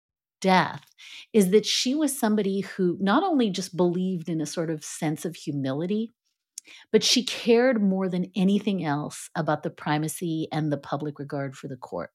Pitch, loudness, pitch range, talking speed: 180 Hz, -25 LUFS, 155-210 Hz, 175 wpm